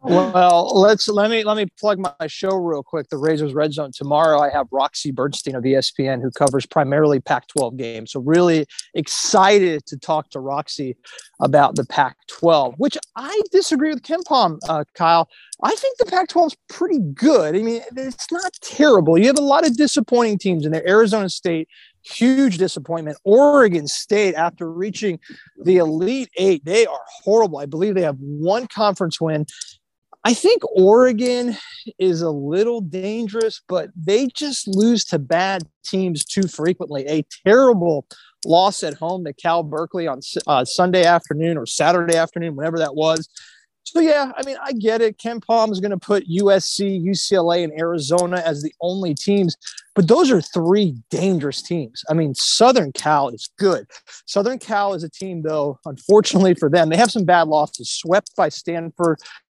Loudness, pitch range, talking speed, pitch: -18 LUFS, 160-225 Hz, 170 wpm, 180 Hz